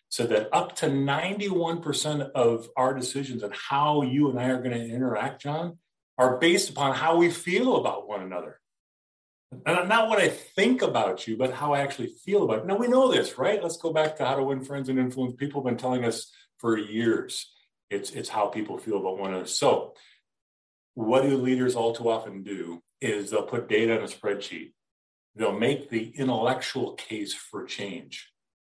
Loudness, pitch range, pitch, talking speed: -26 LUFS, 115-145 Hz, 130 Hz, 195 wpm